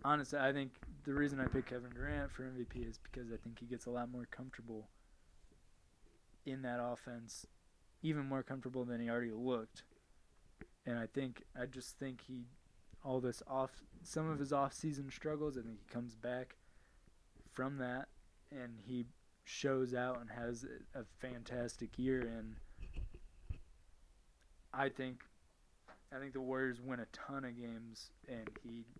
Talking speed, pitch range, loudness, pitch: 160 wpm, 115-130 Hz, -44 LUFS, 125 Hz